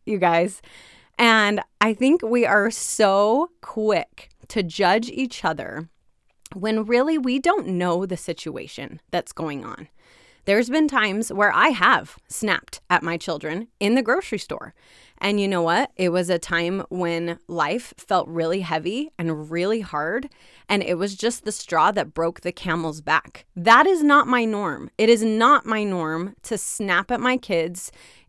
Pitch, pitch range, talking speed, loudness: 205 Hz, 175-235 Hz, 170 wpm, -21 LUFS